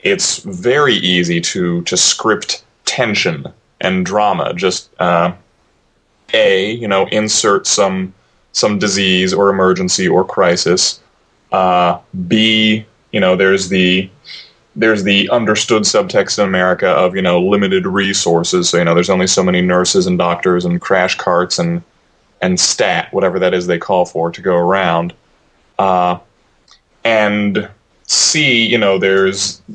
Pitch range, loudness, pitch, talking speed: 90-105 Hz, -13 LUFS, 95 Hz, 140 wpm